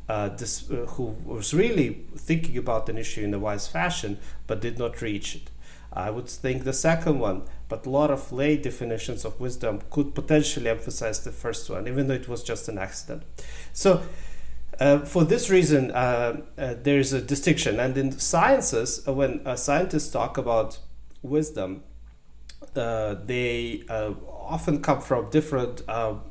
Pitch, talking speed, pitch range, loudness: 125 Hz, 170 wpm, 110-145 Hz, -26 LUFS